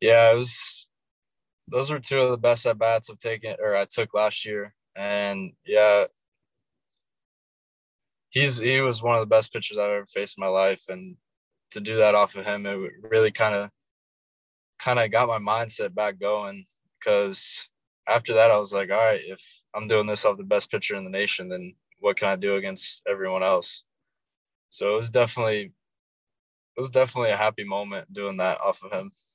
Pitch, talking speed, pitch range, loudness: 105 Hz, 190 wpm, 100-115 Hz, -24 LUFS